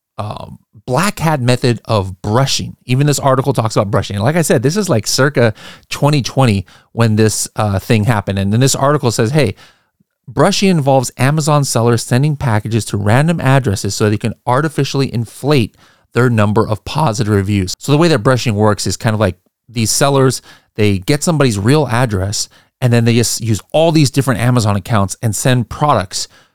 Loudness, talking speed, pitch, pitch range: -14 LUFS, 185 wpm, 120 Hz, 105-140 Hz